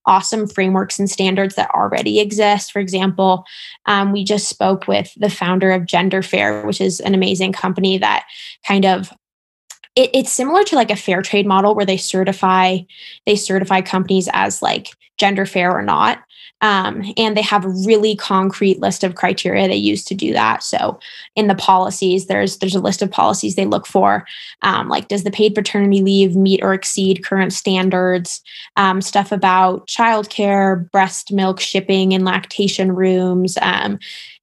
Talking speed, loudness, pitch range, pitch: 175 wpm, -16 LUFS, 190-205 Hz, 195 Hz